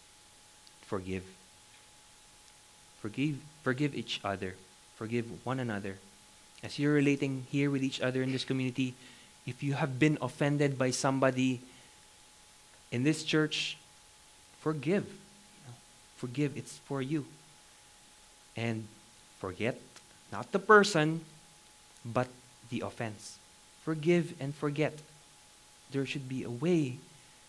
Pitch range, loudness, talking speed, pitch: 115-150 Hz, -32 LUFS, 110 wpm, 130 Hz